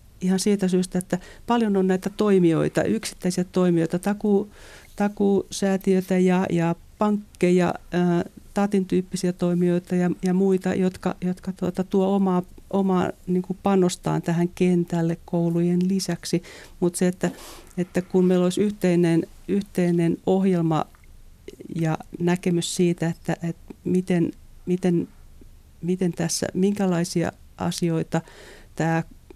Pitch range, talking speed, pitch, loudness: 175-190 Hz, 110 wpm, 180 Hz, -23 LUFS